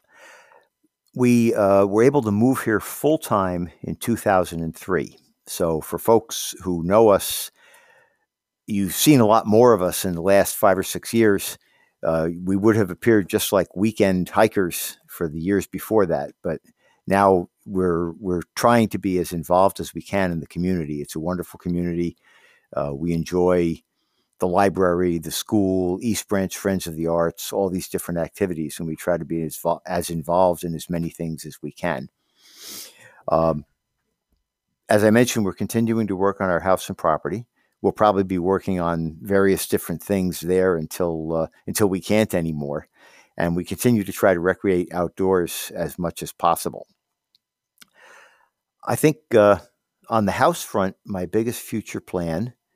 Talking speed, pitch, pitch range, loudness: 165 wpm, 95 Hz, 85-105 Hz, -21 LUFS